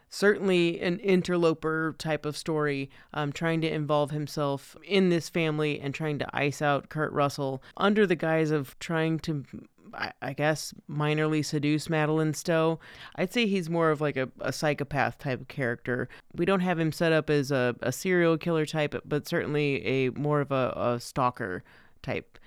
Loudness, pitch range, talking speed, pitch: -28 LUFS, 145-165 Hz, 175 wpm, 155 Hz